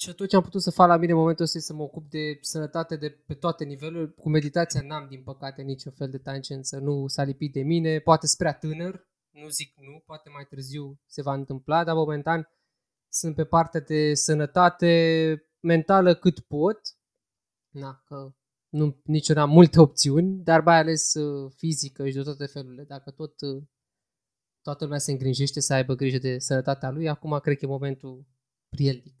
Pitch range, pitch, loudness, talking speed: 140-160 Hz, 150 Hz, -24 LUFS, 185 wpm